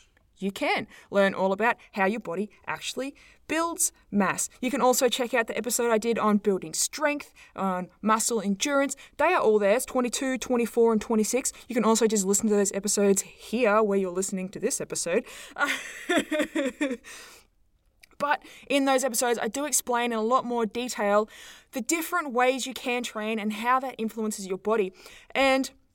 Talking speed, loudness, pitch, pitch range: 175 wpm, -26 LUFS, 235 Hz, 210-265 Hz